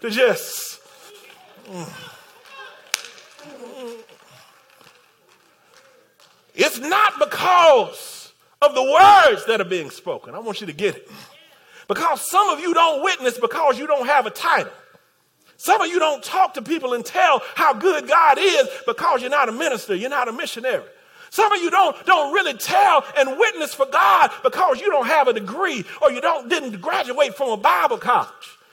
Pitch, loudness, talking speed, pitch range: 325 Hz, -18 LUFS, 165 wpm, 270-400 Hz